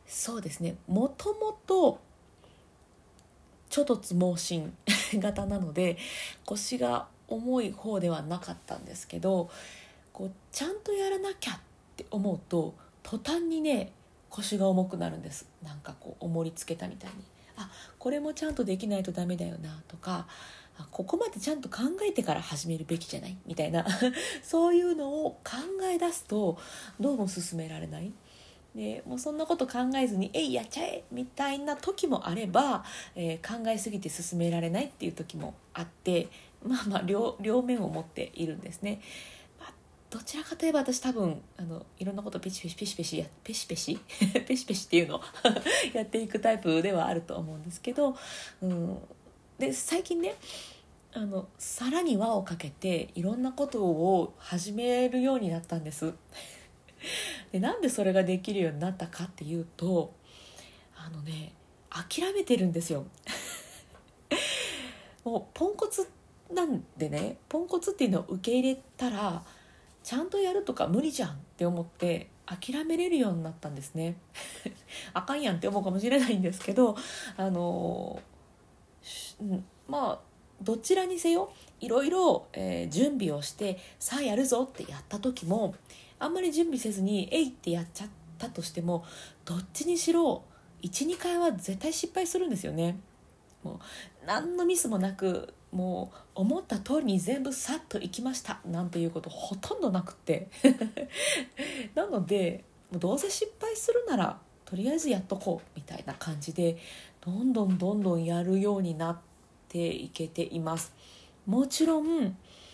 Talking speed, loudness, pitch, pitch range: 315 characters per minute, -31 LUFS, 200 Hz, 170-270 Hz